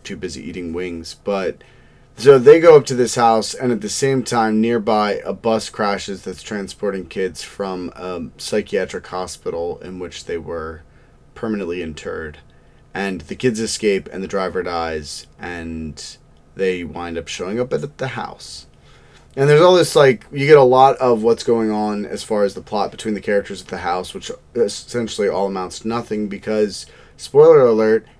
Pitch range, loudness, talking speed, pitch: 90-120 Hz, -18 LUFS, 180 wpm, 105 Hz